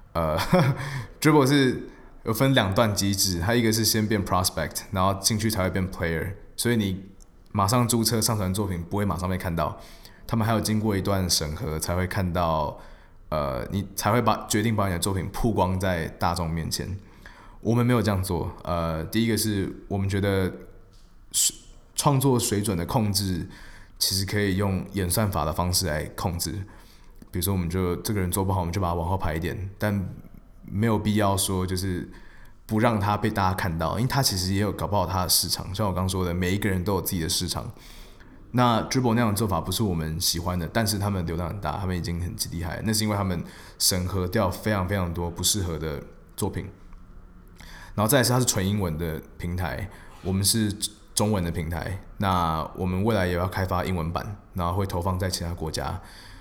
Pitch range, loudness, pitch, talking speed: 90-105 Hz, -25 LUFS, 95 Hz, 310 characters per minute